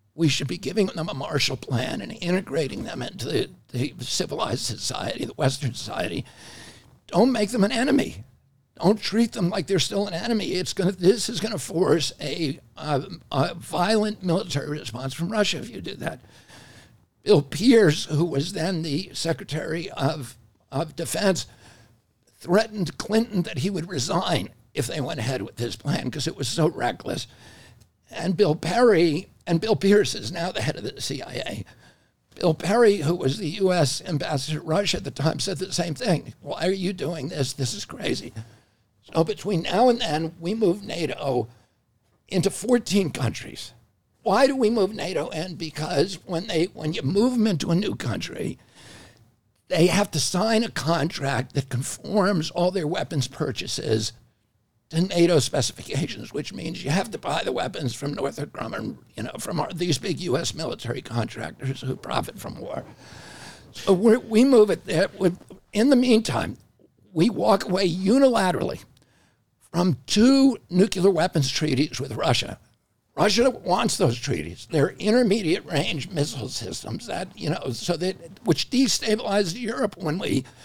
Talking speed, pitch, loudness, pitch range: 165 wpm, 165 Hz, -24 LUFS, 130-195 Hz